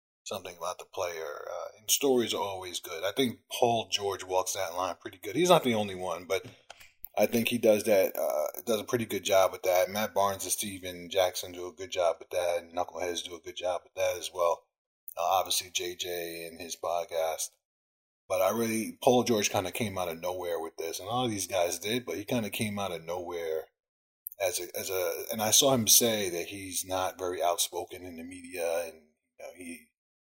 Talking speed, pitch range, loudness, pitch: 220 wpm, 90-125 Hz, -30 LUFS, 100 Hz